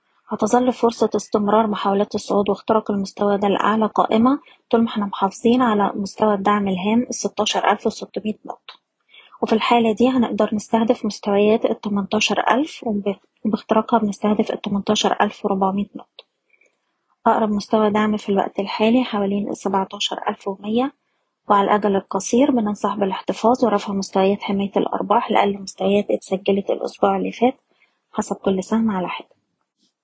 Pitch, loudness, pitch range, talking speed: 210 Hz, -20 LUFS, 200-230 Hz, 130 wpm